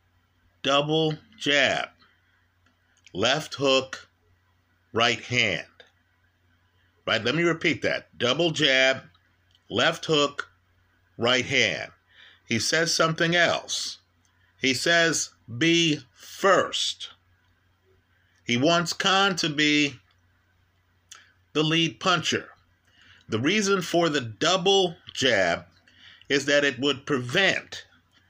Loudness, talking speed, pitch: -23 LUFS, 95 wpm, 115 Hz